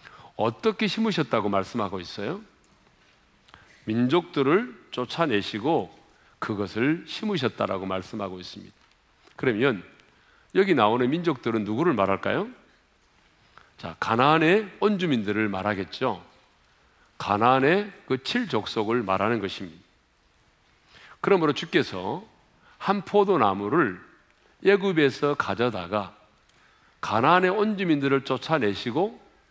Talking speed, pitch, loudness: 255 characters per minute, 120 Hz, -25 LUFS